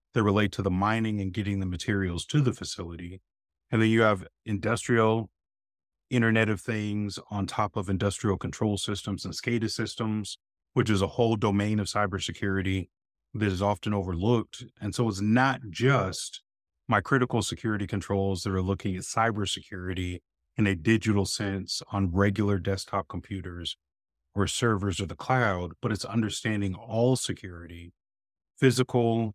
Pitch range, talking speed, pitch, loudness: 95-115 Hz, 150 wpm, 100 Hz, -28 LUFS